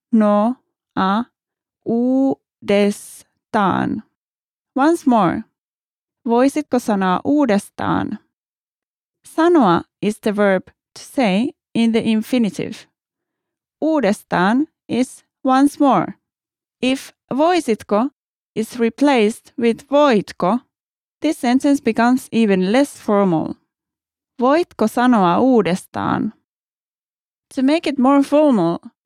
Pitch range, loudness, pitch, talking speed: 215-280 Hz, -18 LUFS, 245 Hz, 85 wpm